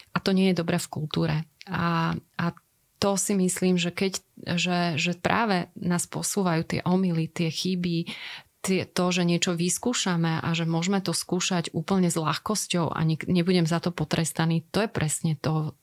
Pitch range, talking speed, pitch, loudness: 165-185 Hz, 175 wpm, 175 Hz, -26 LUFS